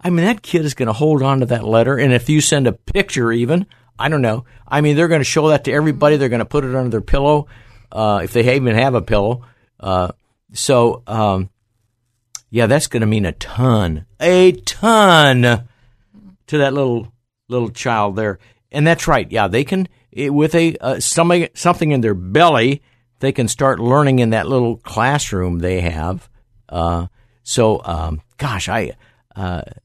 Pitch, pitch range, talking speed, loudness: 120 Hz, 110-145 Hz, 190 wpm, -16 LUFS